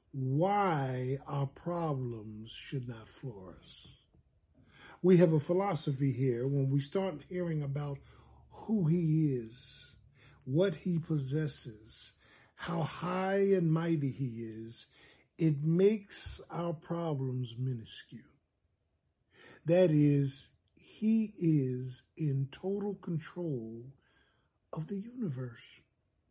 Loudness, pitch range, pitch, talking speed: -33 LUFS, 130-175 Hz, 145 Hz, 100 wpm